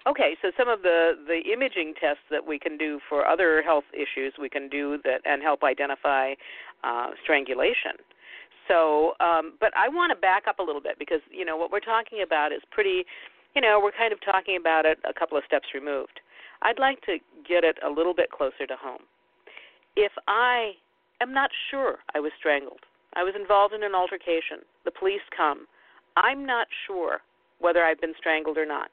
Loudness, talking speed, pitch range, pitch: -25 LUFS, 195 wpm, 155-245 Hz, 175 Hz